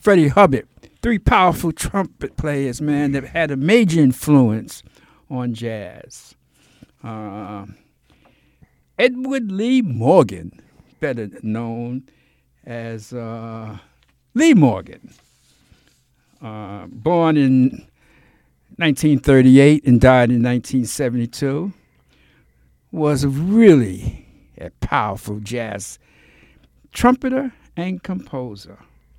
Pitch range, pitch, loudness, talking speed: 110-160 Hz, 130 Hz, -17 LUFS, 80 wpm